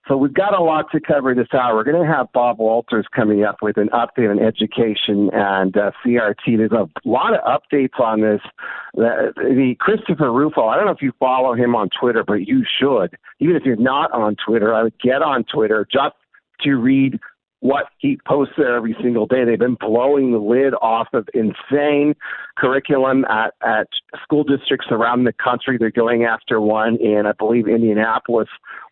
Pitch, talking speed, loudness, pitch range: 120 Hz, 195 wpm, -17 LUFS, 110-140 Hz